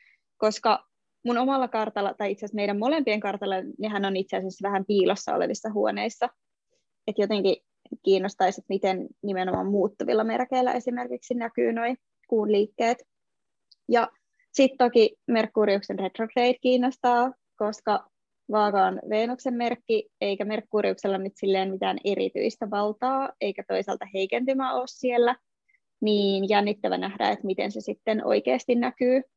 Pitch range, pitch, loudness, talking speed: 200-250 Hz, 220 Hz, -26 LUFS, 130 wpm